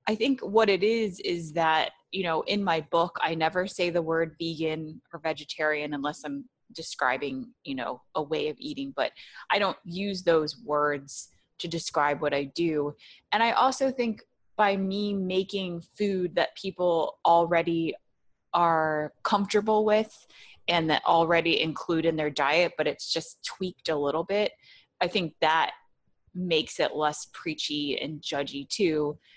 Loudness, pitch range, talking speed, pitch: -27 LUFS, 155-195 Hz, 160 wpm, 170 Hz